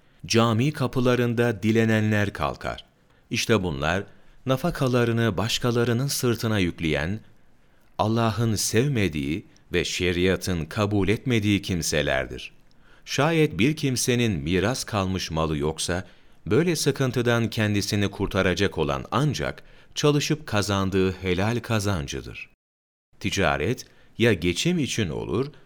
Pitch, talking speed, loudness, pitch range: 105 Hz, 90 wpm, -24 LUFS, 90-120 Hz